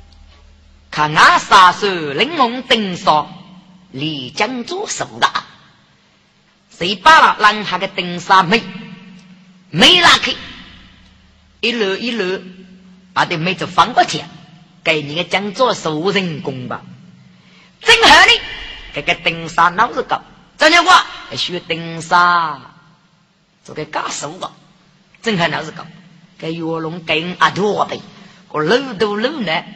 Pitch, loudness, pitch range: 180 Hz, -14 LUFS, 160-205 Hz